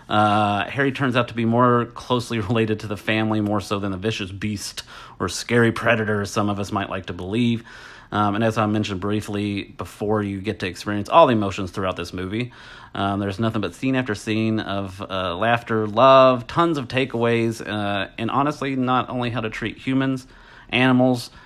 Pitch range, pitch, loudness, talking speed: 100-120 Hz, 110 Hz, -21 LUFS, 195 wpm